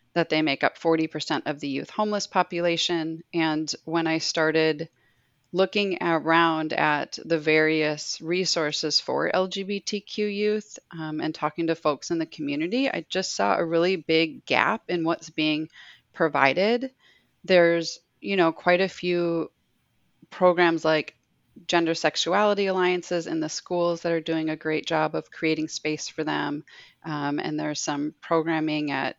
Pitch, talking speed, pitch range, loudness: 165 Hz, 150 wpm, 155-180 Hz, -25 LUFS